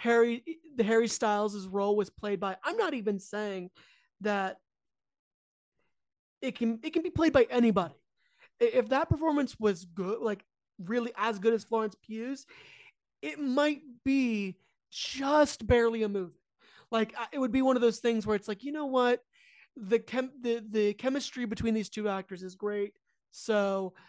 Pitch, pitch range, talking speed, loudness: 230 Hz, 210-260 Hz, 165 wpm, -30 LUFS